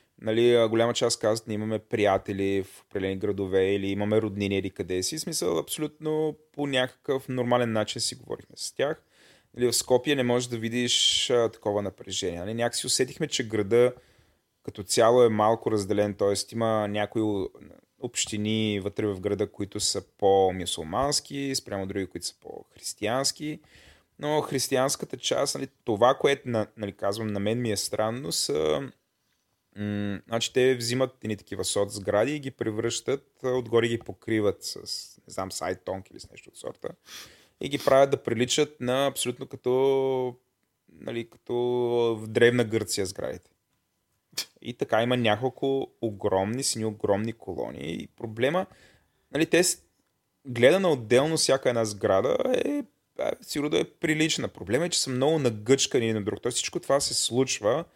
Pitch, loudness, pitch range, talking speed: 115 Hz, -26 LUFS, 105-130 Hz, 155 wpm